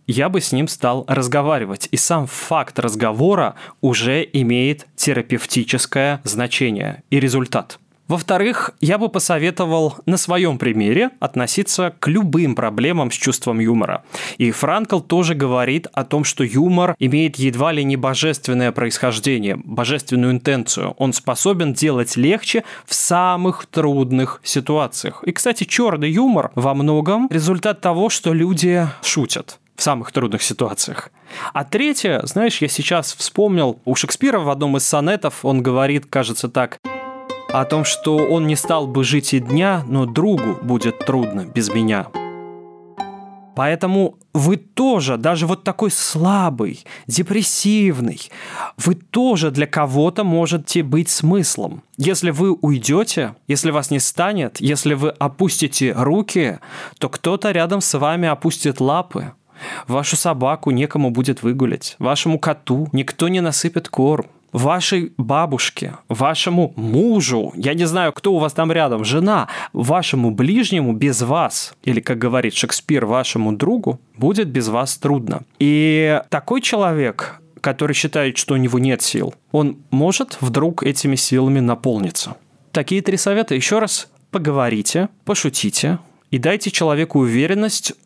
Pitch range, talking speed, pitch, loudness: 130-175 Hz, 135 wpm, 150 Hz, -18 LUFS